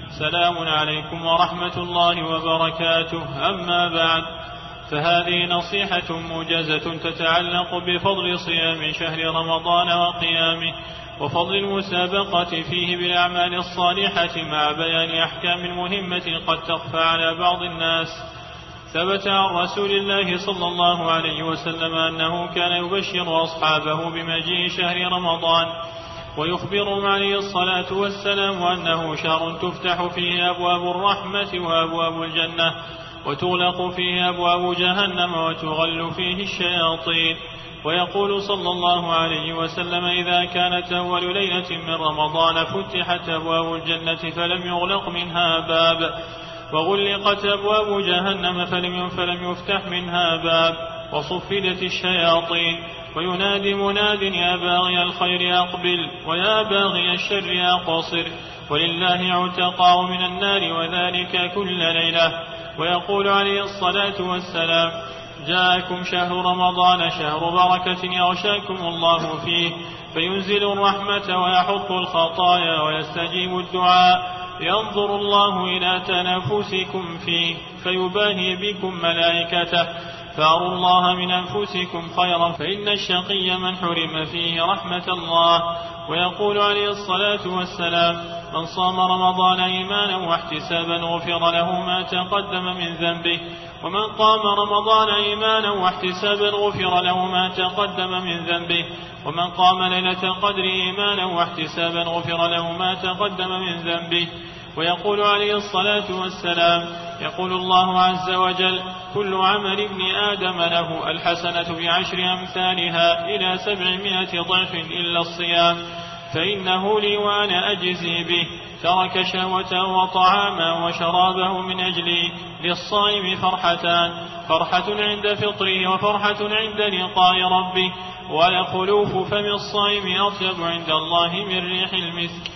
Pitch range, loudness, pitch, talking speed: 170-185 Hz, -20 LUFS, 180 Hz, 105 wpm